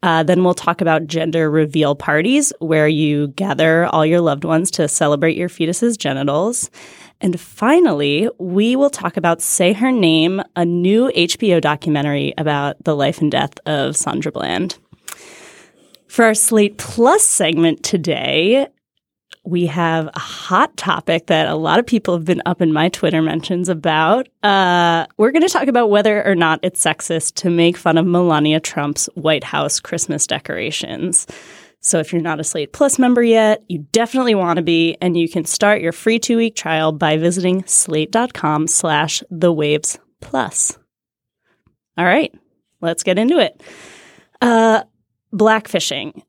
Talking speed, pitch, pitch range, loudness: 155 wpm, 175 Hz, 160-215 Hz, -16 LUFS